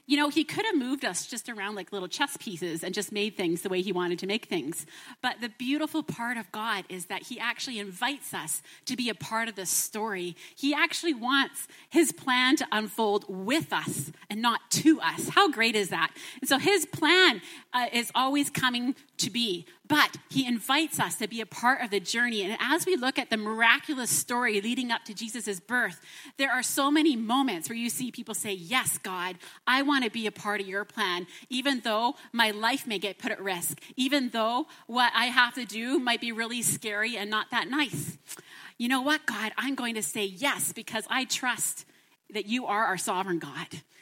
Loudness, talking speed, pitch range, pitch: -28 LUFS, 215 wpm, 205-270 Hz, 235 Hz